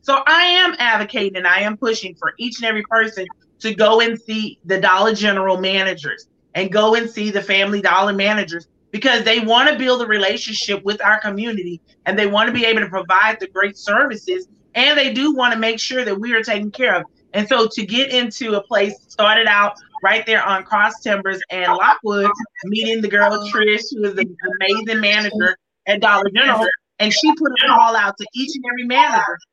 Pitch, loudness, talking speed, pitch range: 215 Hz, -16 LUFS, 205 wpm, 200-235 Hz